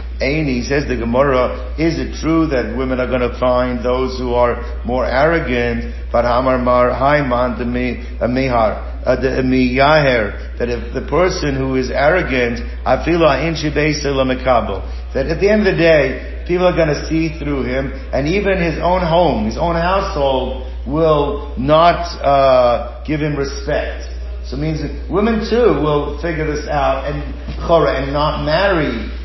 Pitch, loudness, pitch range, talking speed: 135 Hz, -16 LUFS, 125-160 Hz, 135 wpm